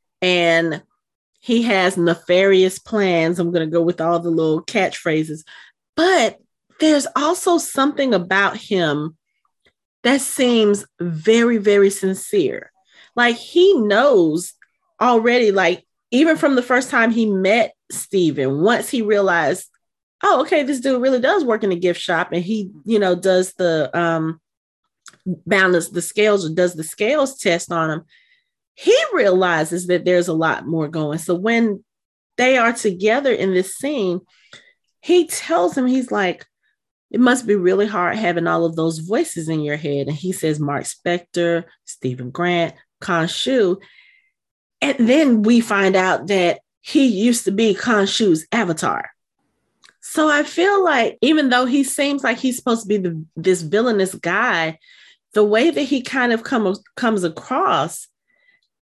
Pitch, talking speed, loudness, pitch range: 200 Hz, 155 wpm, -18 LUFS, 170-250 Hz